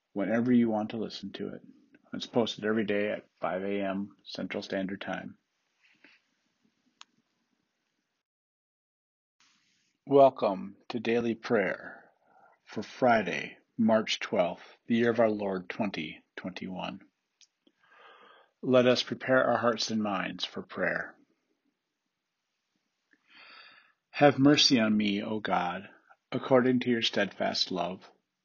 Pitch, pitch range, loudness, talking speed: 115 Hz, 105-125 Hz, -28 LUFS, 110 wpm